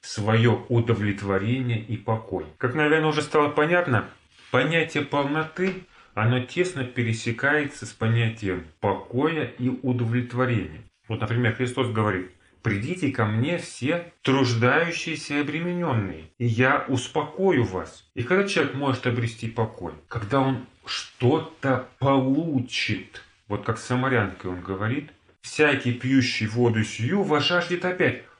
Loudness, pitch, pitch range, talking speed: -25 LUFS, 125 Hz, 110-145 Hz, 120 wpm